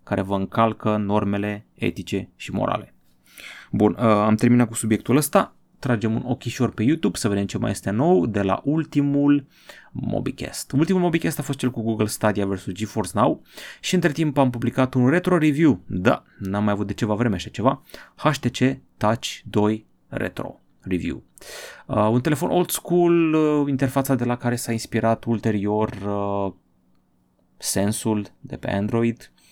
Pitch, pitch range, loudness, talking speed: 115 Hz, 105-140 Hz, -22 LUFS, 155 wpm